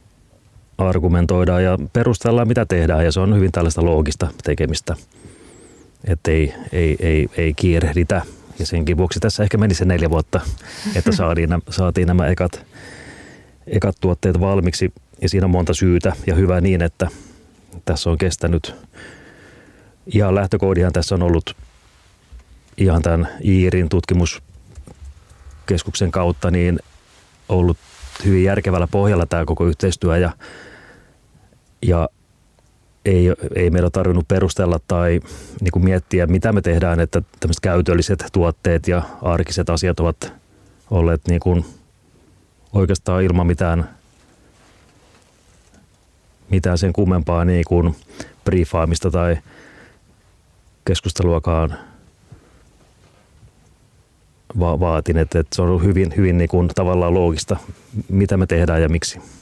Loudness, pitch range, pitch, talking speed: -18 LUFS, 85-95 Hz, 90 Hz, 120 wpm